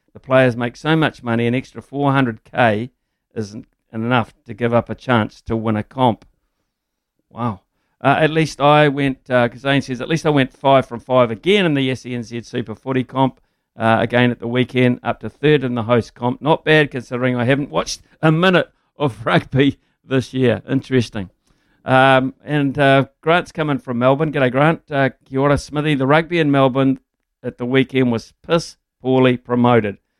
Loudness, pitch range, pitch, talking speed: -17 LUFS, 120-140 Hz, 130 Hz, 180 wpm